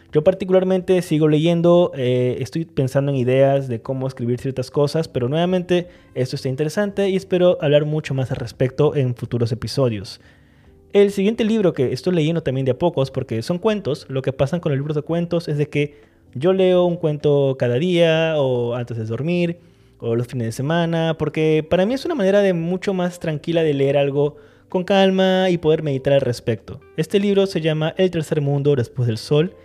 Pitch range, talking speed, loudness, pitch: 130-175 Hz, 200 wpm, -19 LUFS, 150 Hz